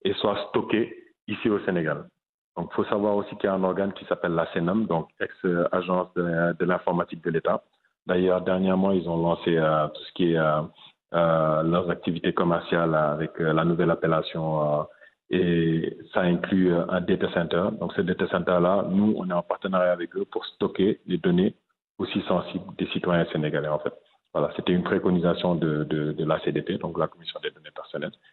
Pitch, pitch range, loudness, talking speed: 85 Hz, 80-90 Hz, -25 LUFS, 195 wpm